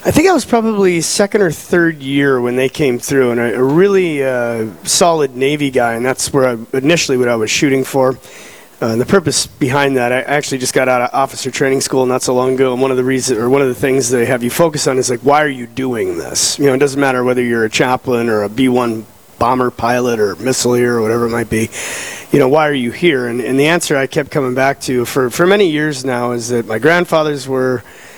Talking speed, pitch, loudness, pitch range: 255 wpm, 130 Hz, -14 LUFS, 120-145 Hz